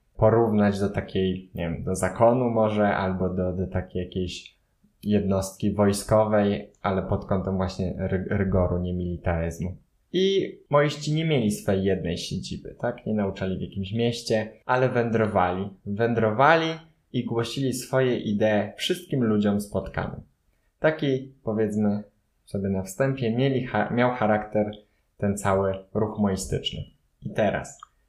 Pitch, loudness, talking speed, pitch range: 105 Hz, -25 LUFS, 125 wpm, 95-115 Hz